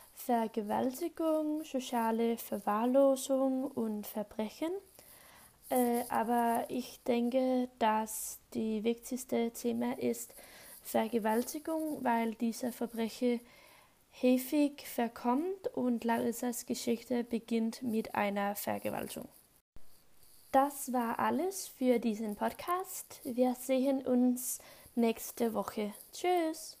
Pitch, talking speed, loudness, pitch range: 245 Hz, 85 wpm, -34 LUFS, 230-265 Hz